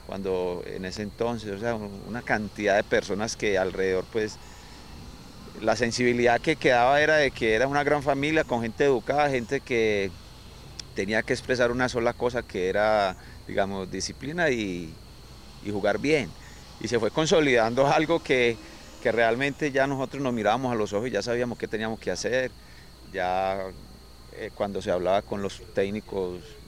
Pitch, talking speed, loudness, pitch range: 115 Hz, 165 wpm, -26 LUFS, 95-130 Hz